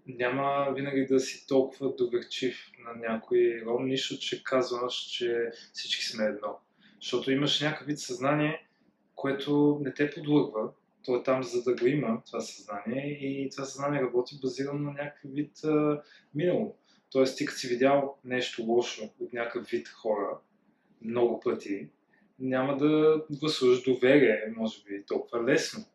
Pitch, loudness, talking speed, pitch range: 135 Hz, -29 LUFS, 150 wpm, 120-145 Hz